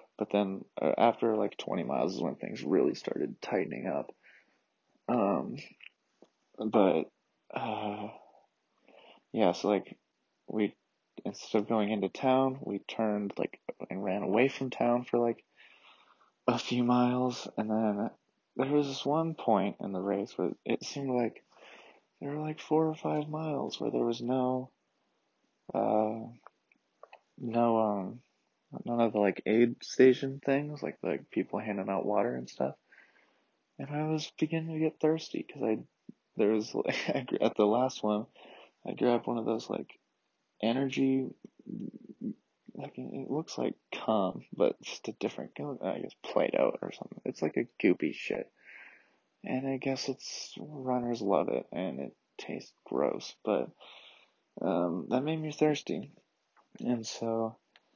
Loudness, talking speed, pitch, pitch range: -32 LUFS, 150 wpm, 125 Hz, 110-135 Hz